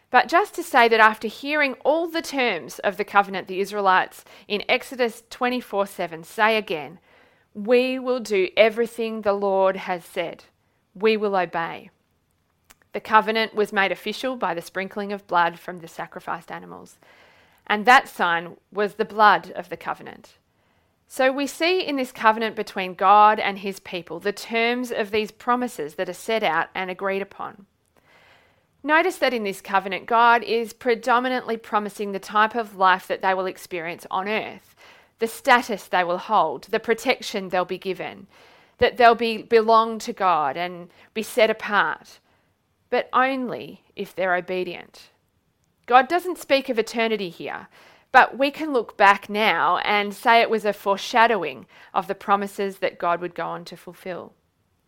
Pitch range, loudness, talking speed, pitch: 190-235 Hz, -22 LUFS, 165 wpm, 210 Hz